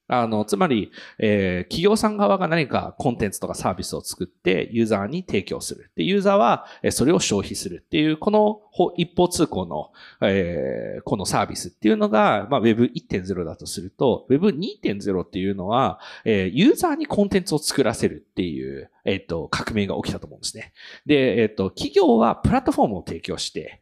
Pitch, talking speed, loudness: 125 Hz, 390 characters per minute, -22 LUFS